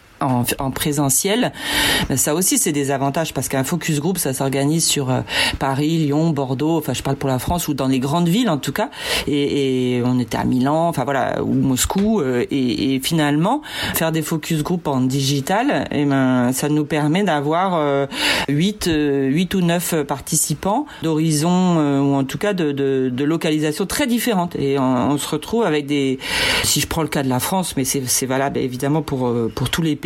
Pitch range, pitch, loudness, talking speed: 135-165 Hz, 145 Hz, -19 LUFS, 195 wpm